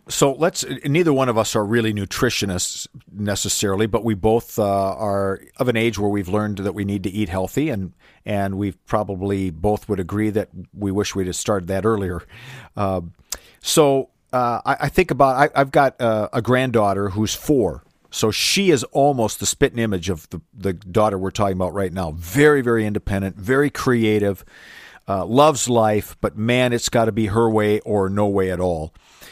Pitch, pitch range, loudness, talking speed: 105 Hz, 100-120 Hz, -20 LUFS, 190 wpm